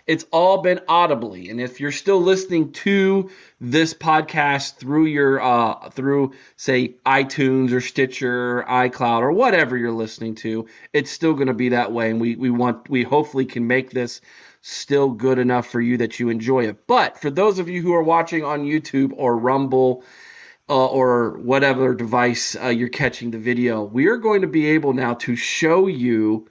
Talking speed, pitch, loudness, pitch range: 185 wpm, 130 Hz, -19 LUFS, 120-150 Hz